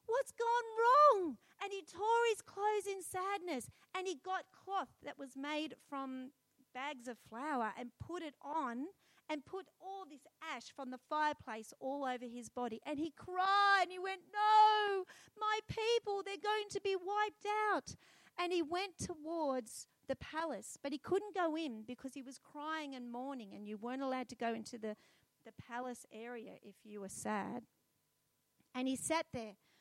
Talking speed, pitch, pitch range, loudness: 175 wpm, 310 Hz, 255-390 Hz, -38 LUFS